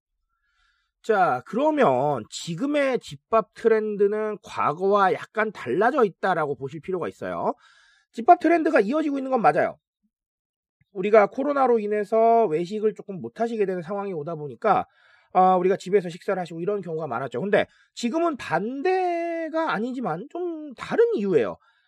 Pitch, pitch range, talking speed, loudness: 225 Hz, 195-290 Hz, 325 characters per minute, -24 LUFS